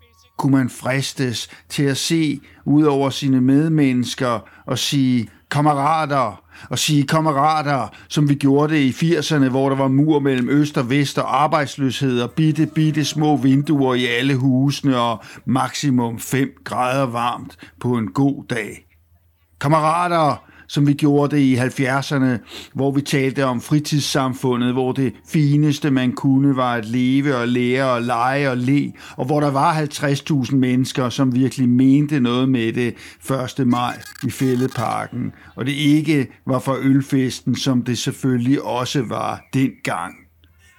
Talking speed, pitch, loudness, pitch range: 150 wpm, 135 Hz, -19 LUFS, 125-145 Hz